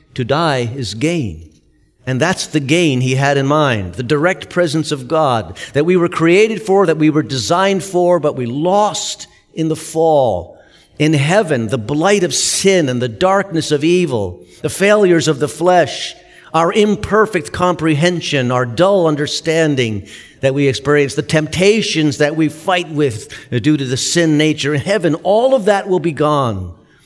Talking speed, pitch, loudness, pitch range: 170 wpm, 155 Hz, -14 LUFS, 135-175 Hz